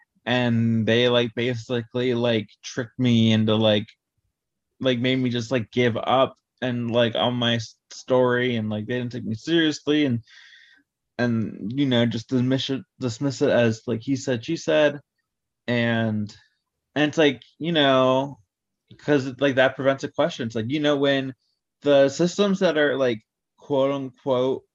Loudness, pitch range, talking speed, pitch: -23 LUFS, 115-140 Hz, 160 wpm, 125 Hz